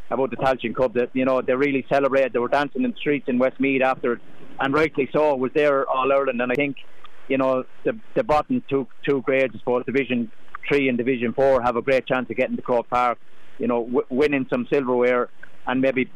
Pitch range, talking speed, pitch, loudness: 125-140 Hz, 230 wpm, 130 Hz, -22 LUFS